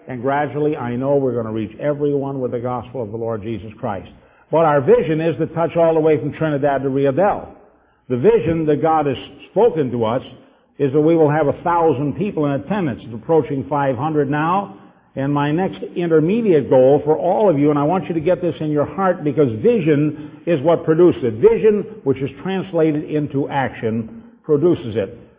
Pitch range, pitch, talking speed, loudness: 135-165 Hz, 150 Hz, 200 wpm, -18 LUFS